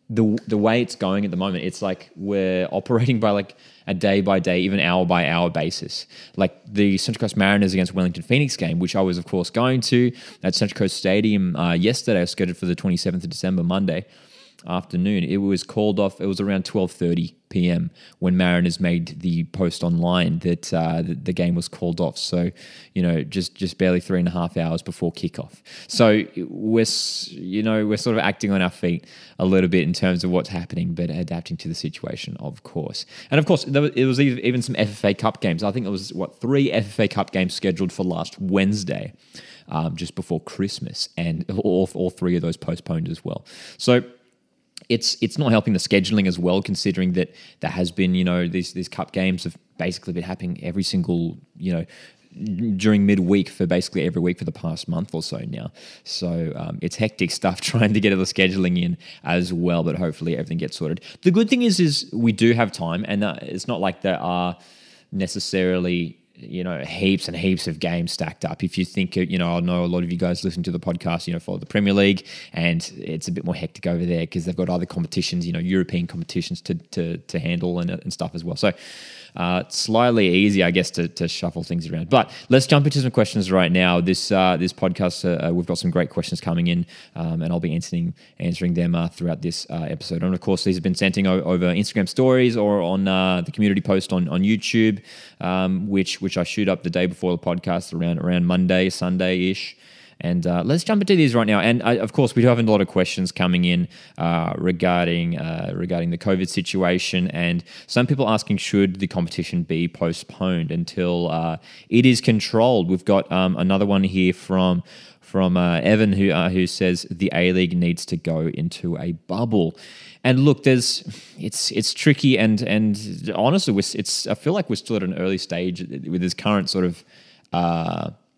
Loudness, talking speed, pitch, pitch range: -21 LUFS, 215 wpm, 95 Hz, 90-110 Hz